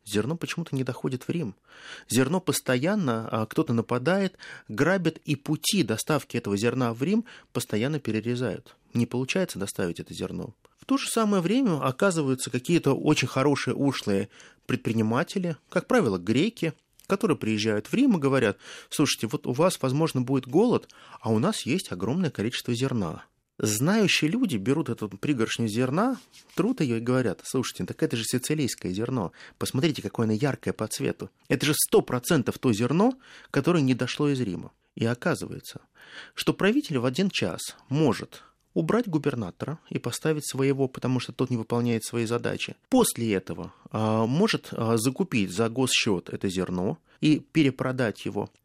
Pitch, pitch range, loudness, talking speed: 130 Hz, 115-160 Hz, -26 LUFS, 155 wpm